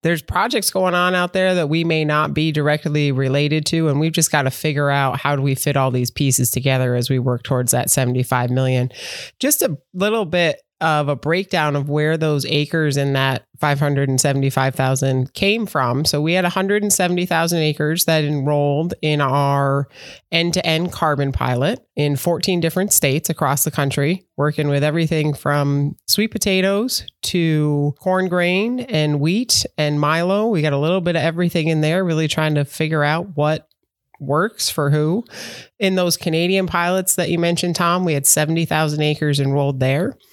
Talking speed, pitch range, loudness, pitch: 175 wpm, 140-175 Hz, -18 LUFS, 155 Hz